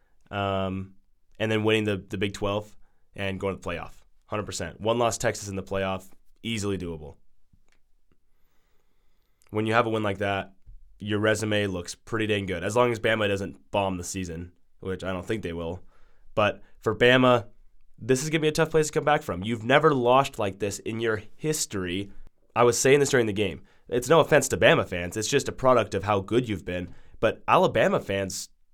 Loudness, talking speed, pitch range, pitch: -25 LUFS, 205 wpm, 95-115 Hz, 100 Hz